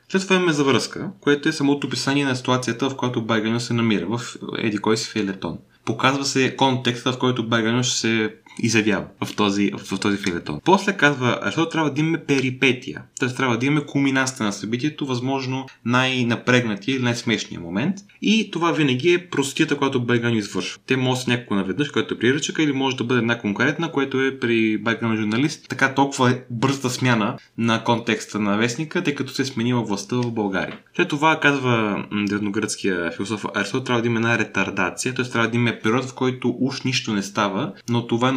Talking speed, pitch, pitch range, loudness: 190 wpm, 125 Hz, 110-135 Hz, -21 LUFS